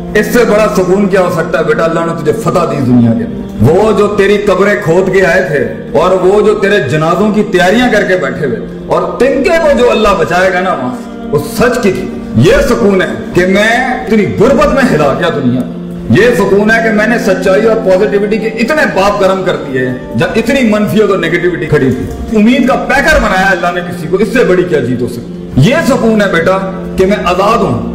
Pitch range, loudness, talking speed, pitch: 175-220 Hz, -9 LUFS, 225 wpm, 195 Hz